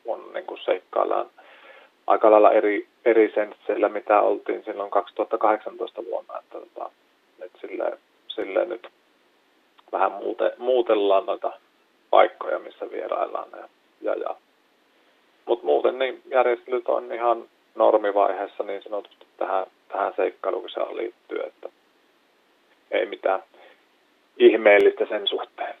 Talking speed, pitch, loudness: 105 wpm, 380 Hz, -23 LUFS